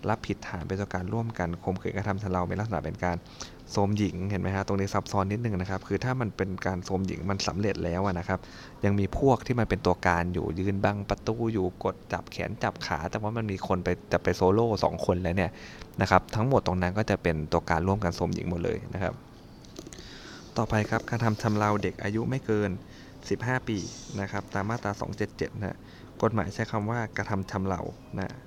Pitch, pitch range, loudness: 100 Hz, 90-110 Hz, -29 LUFS